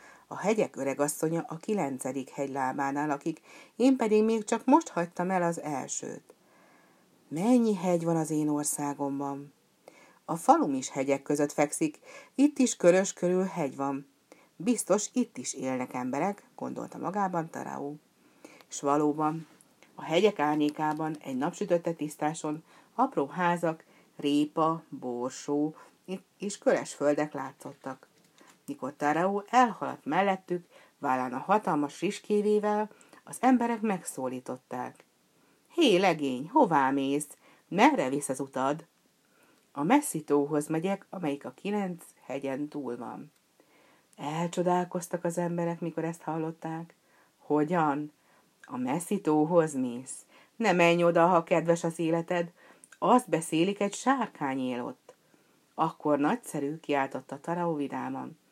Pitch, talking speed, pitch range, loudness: 165 Hz, 120 wpm, 145-190 Hz, -29 LUFS